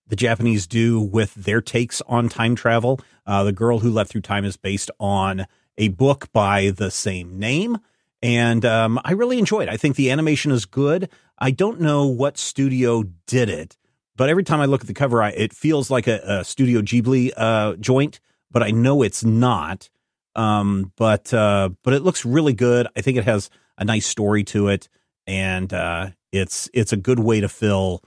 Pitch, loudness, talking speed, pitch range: 115 Hz, -20 LUFS, 200 wpm, 100-130 Hz